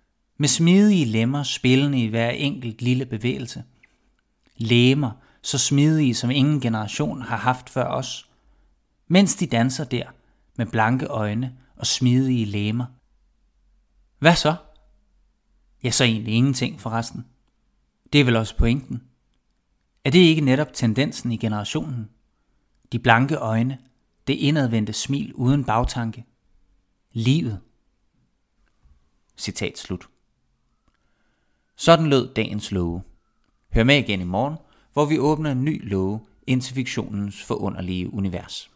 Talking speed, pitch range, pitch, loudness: 120 wpm, 110-135 Hz, 120 Hz, -22 LUFS